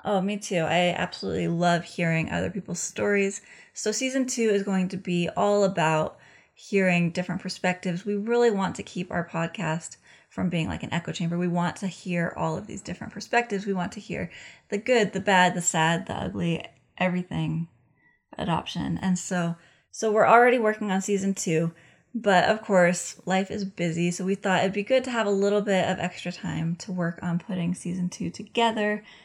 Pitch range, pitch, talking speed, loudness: 175-205 Hz, 185 Hz, 195 wpm, -26 LUFS